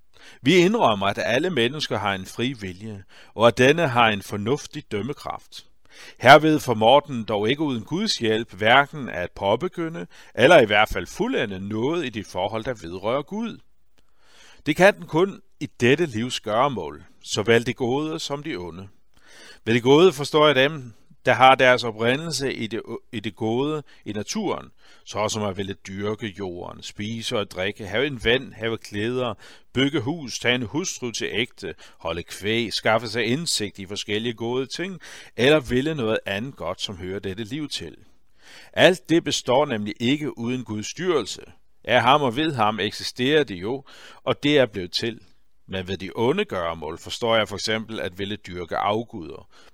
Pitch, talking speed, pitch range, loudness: 115 Hz, 175 wpm, 105-140 Hz, -22 LUFS